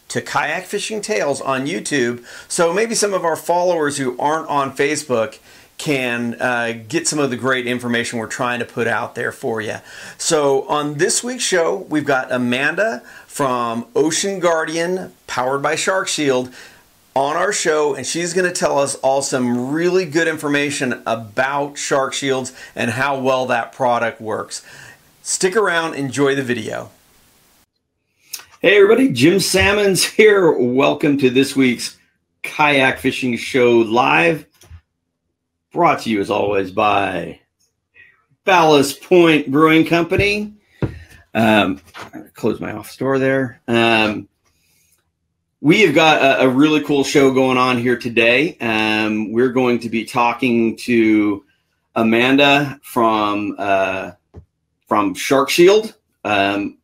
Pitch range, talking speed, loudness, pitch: 115-155 Hz, 135 wpm, -17 LUFS, 130 Hz